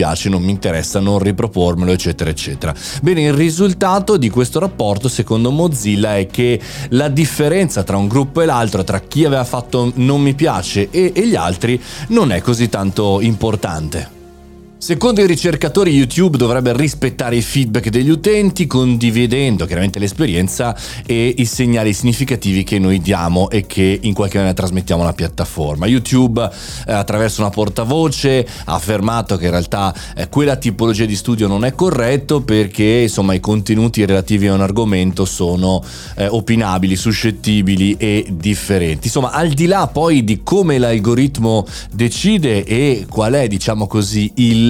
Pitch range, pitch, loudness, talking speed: 100-135 Hz, 115 Hz, -15 LUFS, 150 wpm